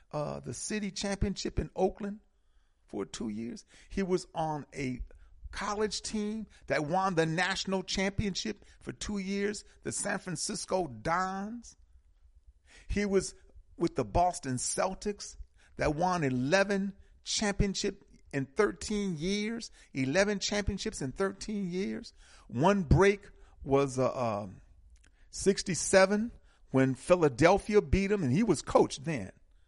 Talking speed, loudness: 120 wpm, -31 LUFS